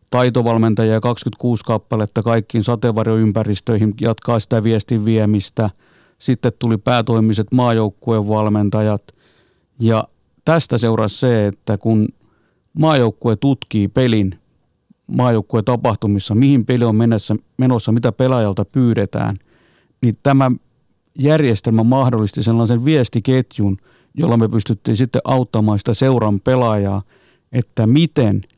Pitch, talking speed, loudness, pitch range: 115 Hz, 100 wpm, -16 LUFS, 110-125 Hz